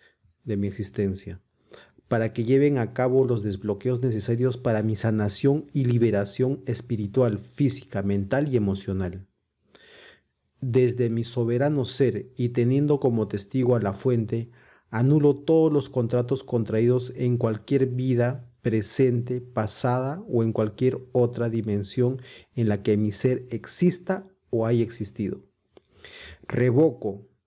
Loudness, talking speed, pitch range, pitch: -25 LUFS, 125 wpm, 110-130 Hz, 120 Hz